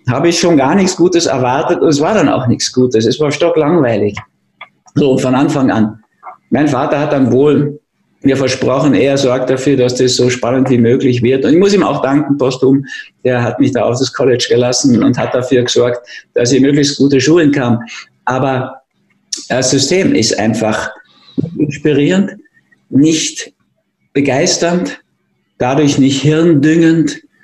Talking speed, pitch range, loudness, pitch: 160 wpm, 125-155 Hz, -12 LUFS, 135 Hz